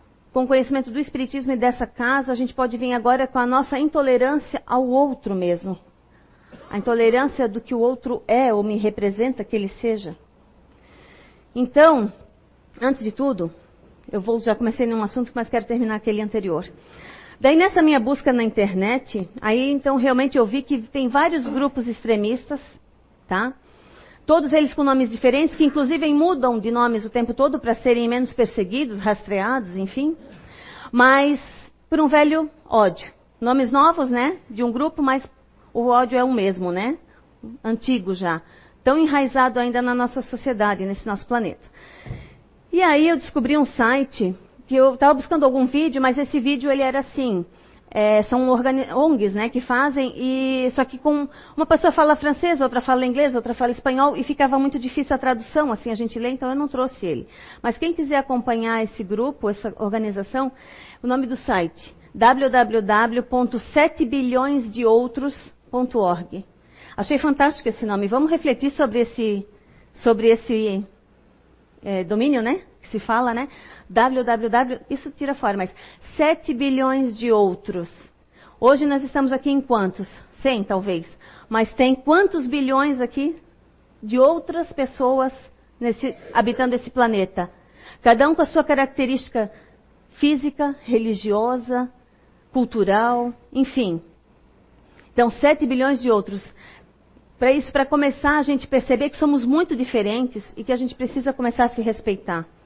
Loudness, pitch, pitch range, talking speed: -20 LUFS, 255 Hz, 225-275 Hz, 150 wpm